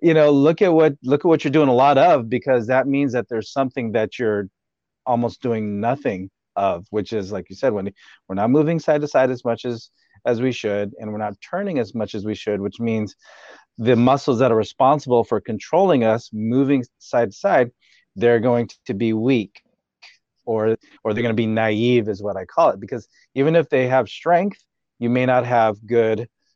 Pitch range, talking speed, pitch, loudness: 110-130 Hz, 210 wpm, 120 Hz, -20 LUFS